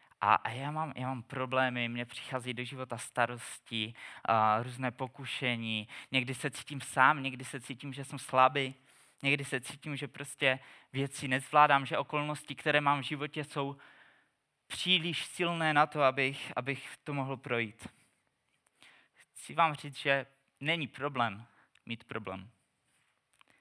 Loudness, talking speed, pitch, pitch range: -32 LUFS, 140 wpm, 135 Hz, 125-145 Hz